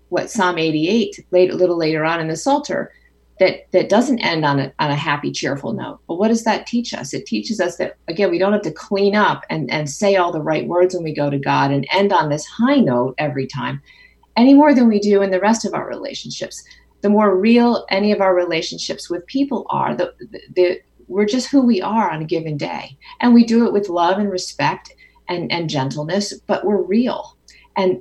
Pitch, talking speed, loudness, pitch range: 185 Hz, 230 wpm, -18 LUFS, 160-215 Hz